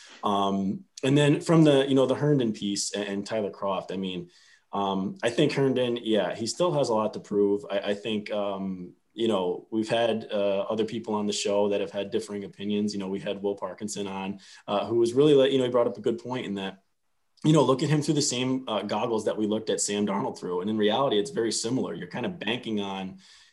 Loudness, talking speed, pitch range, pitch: -27 LUFS, 245 wpm, 100-120 Hz, 105 Hz